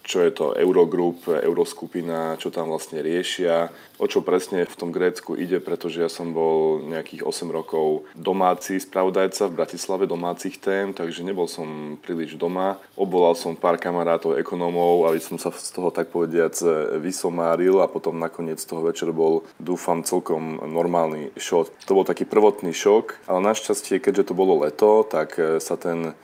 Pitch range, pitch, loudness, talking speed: 80-95 Hz, 85 Hz, -23 LUFS, 160 wpm